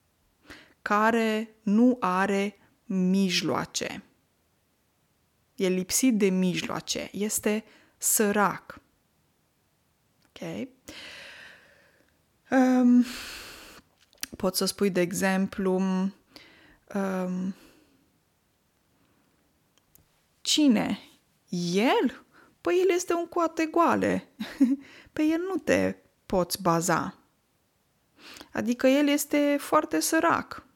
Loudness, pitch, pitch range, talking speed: -26 LUFS, 220 Hz, 190-285 Hz, 75 wpm